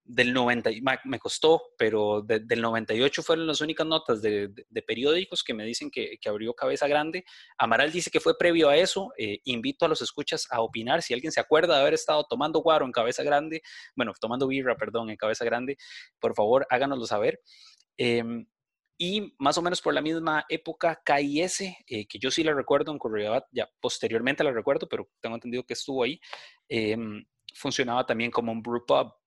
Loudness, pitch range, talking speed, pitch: -27 LUFS, 115-165 Hz, 195 wpm, 145 Hz